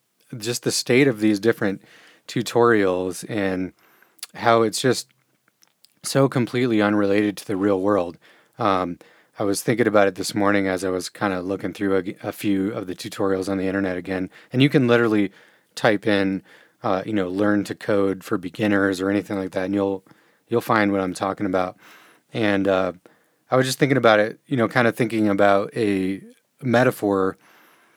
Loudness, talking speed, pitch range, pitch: -22 LUFS, 180 wpm, 95-115 Hz, 100 Hz